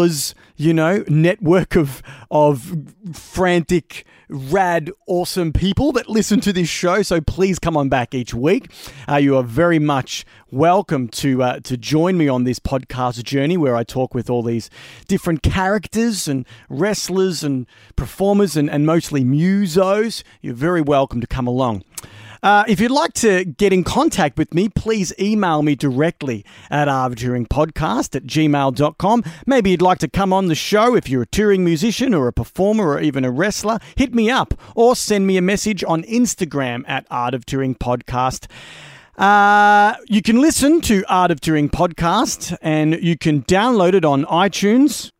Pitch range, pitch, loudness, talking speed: 135-195 Hz, 165 Hz, -17 LUFS, 170 wpm